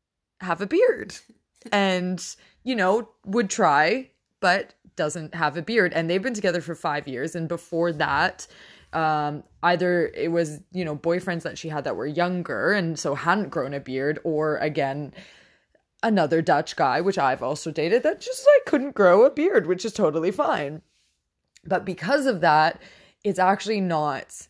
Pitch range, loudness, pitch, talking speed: 155-205 Hz, -23 LUFS, 175 Hz, 170 wpm